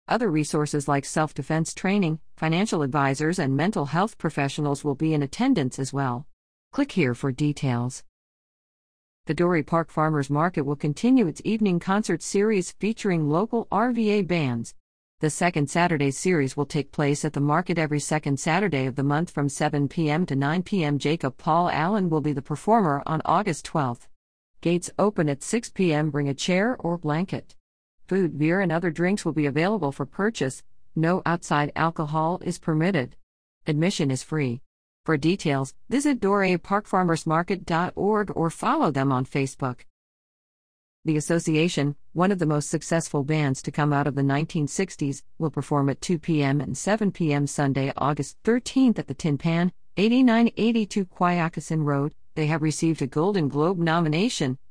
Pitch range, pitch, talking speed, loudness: 145-180 Hz, 160 Hz, 160 wpm, -24 LUFS